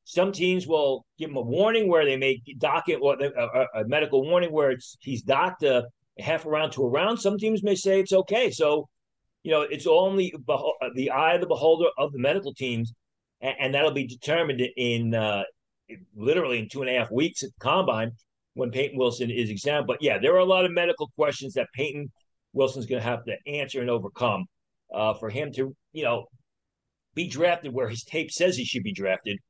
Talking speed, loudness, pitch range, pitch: 215 wpm, -25 LUFS, 125-160 Hz, 135 Hz